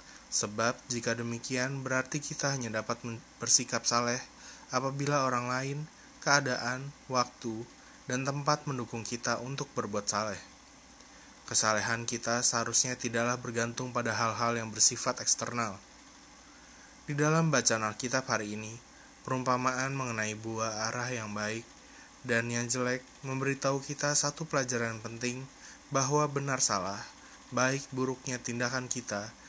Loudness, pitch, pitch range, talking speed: -31 LUFS, 125 Hz, 115-140 Hz, 120 wpm